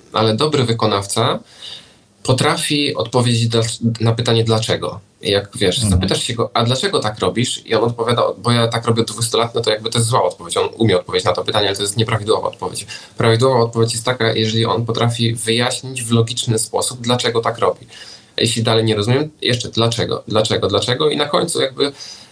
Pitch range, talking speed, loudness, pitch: 110-125 Hz, 195 wpm, -17 LUFS, 115 Hz